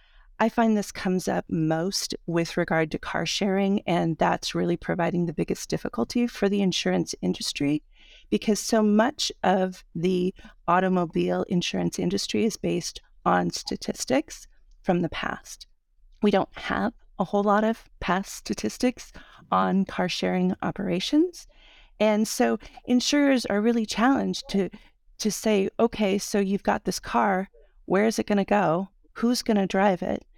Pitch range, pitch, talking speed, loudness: 175-215 Hz, 195 Hz, 150 wpm, -25 LUFS